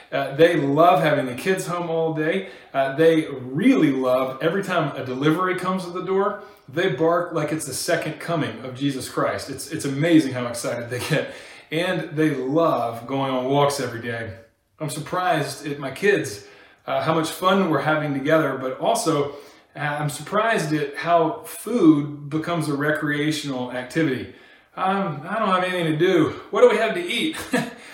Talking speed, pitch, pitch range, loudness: 180 wpm, 155 Hz, 135-175 Hz, -22 LUFS